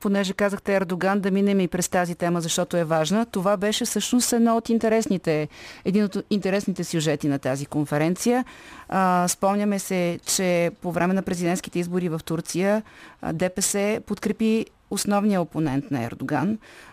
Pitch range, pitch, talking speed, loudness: 175-205 Hz, 190 Hz, 135 wpm, -24 LUFS